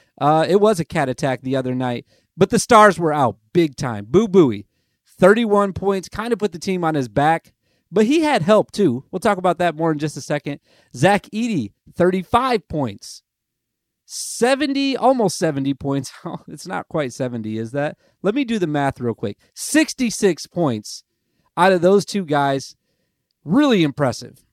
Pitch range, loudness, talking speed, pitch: 140-205 Hz, -19 LUFS, 175 wpm, 170 Hz